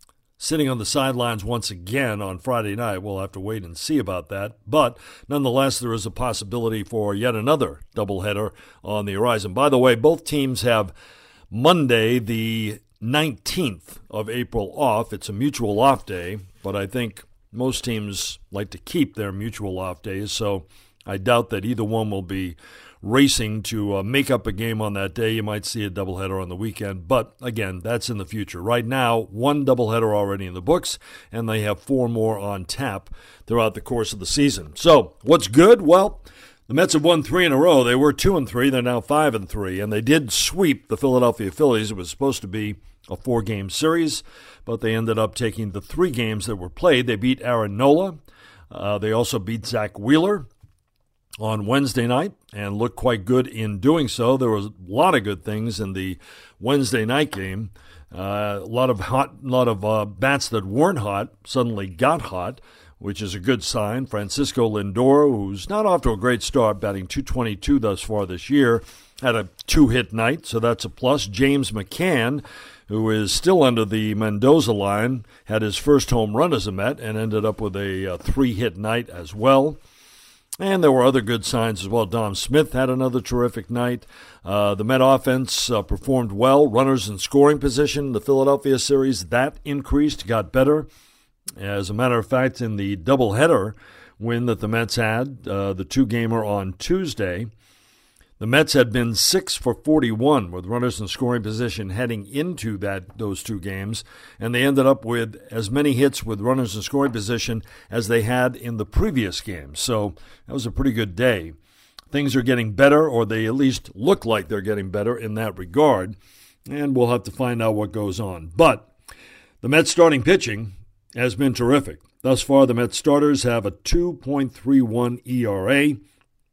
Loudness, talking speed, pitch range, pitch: -21 LUFS, 190 wpm, 105-130 Hz, 115 Hz